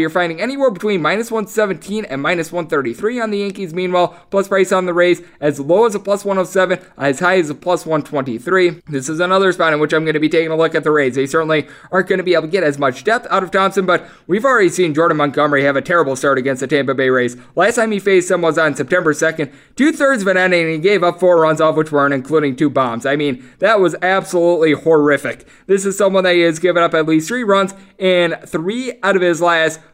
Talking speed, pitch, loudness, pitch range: 250 wpm, 175 Hz, -15 LUFS, 155-190 Hz